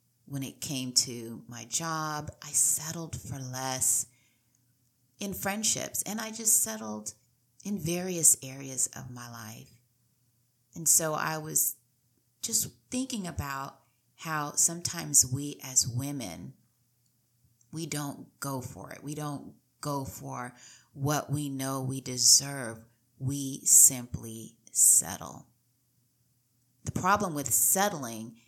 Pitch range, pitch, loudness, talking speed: 120-145 Hz, 130 Hz, -27 LUFS, 115 wpm